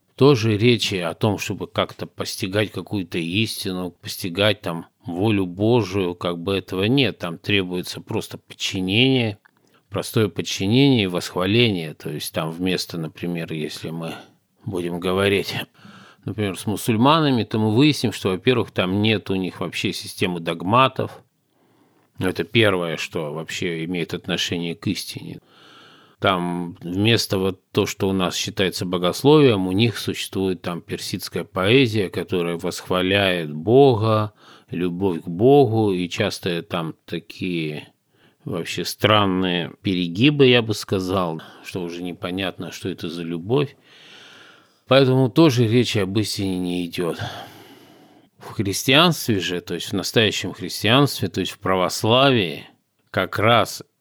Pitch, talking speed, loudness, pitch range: 95 Hz, 130 wpm, -21 LUFS, 90-110 Hz